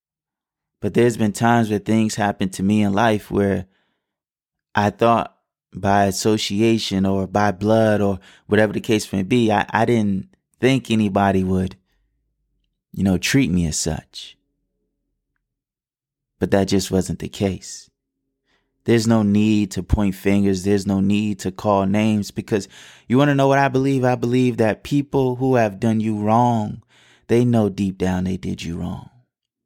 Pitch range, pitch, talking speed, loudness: 95-115 Hz, 105 Hz, 160 wpm, -19 LUFS